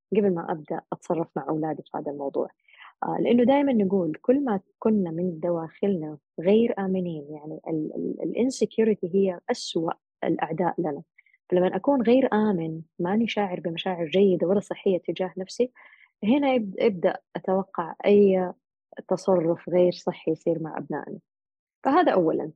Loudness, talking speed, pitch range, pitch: -25 LUFS, 135 wpm, 170-215 Hz, 190 Hz